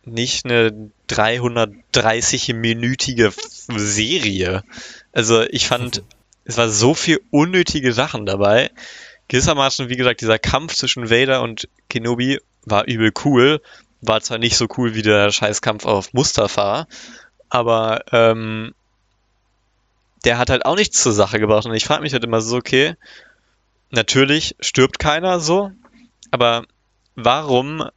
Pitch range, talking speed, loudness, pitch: 110-130 Hz, 130 wpm, -17 LUFS, 120 Hz